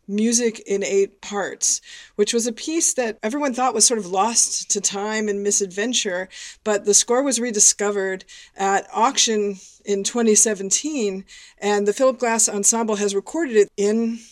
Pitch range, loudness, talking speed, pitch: 200-235 Hz, -19 LUFS, 155 wpm, 215 Hz